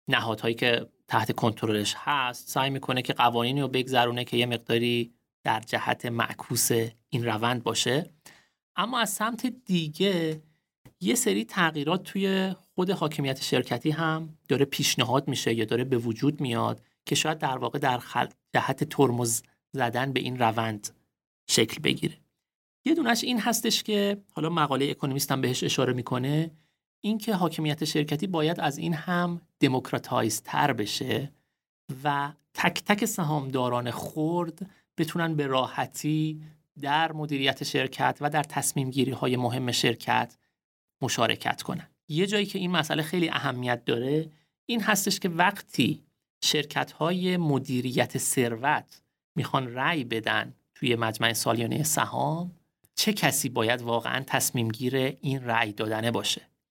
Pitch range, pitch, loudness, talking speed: 125-160 Hz, 140 Hz, -27 LUFS, 135 wpm